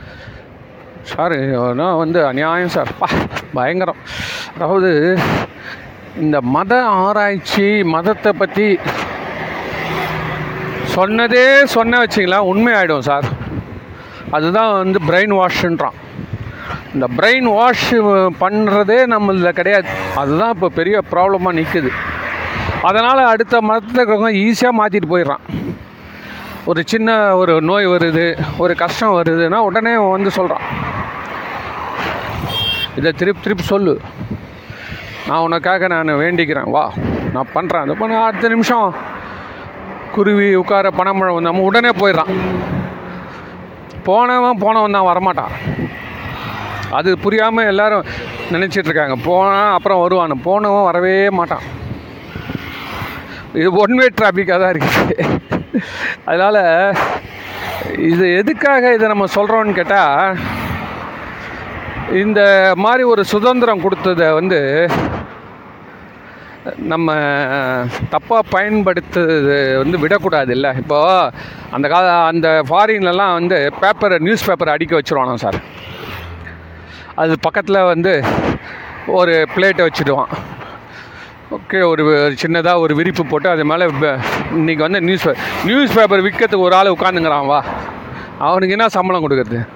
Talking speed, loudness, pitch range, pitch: 100 wpm, -14 LUFS, 165-210 Hz, 185 Hz